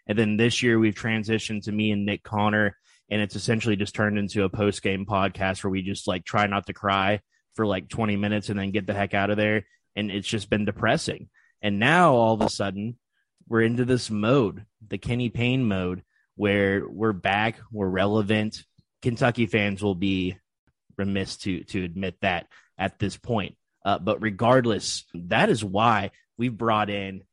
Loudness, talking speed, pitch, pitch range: -25 LUFS, 190 wpm, 105 Hz, 100-110 Hz